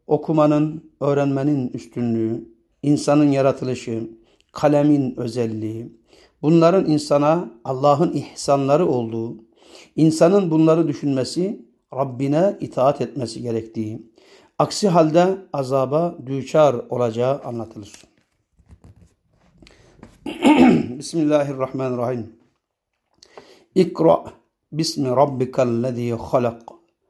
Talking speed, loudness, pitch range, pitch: 65 wpm, -20 LUFS, 120-150 Hz, 135 Hz